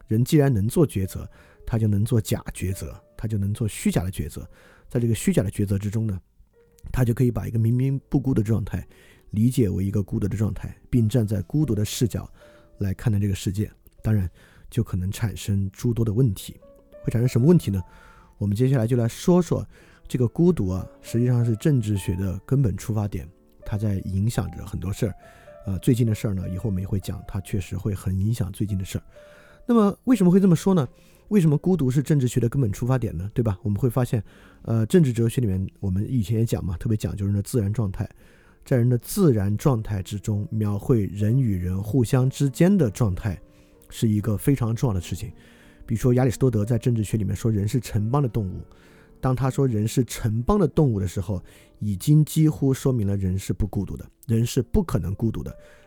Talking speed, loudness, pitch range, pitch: 320 characters per minute, -24 LUFS, 100-130 Hz, 110 Hz